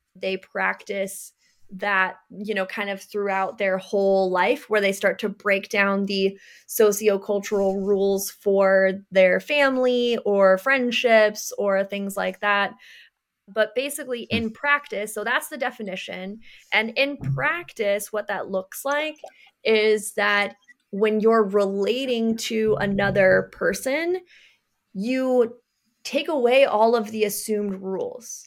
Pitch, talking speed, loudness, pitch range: 210 Hz, 125 wpm, -22 LUFS, 195-240 Hz